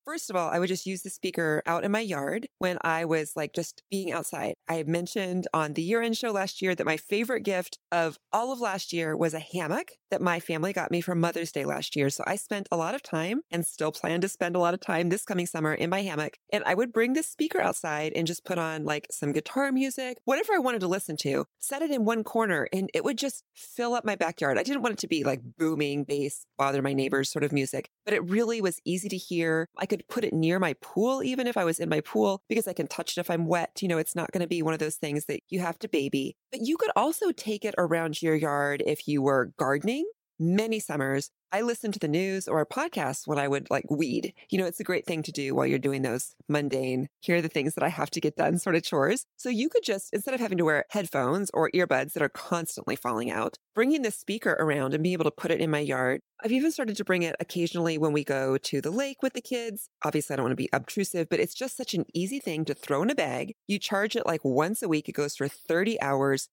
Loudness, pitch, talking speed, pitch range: -29 LUFS, 175 Hz, 265 wpm, 155-210 Hz